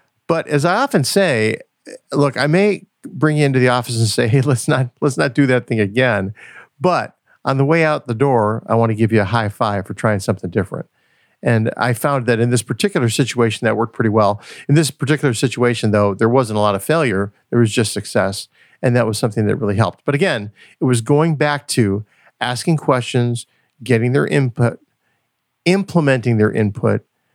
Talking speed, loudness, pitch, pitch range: 200 wpm, -17 LUFS, 120 Hz, 110-140 Hz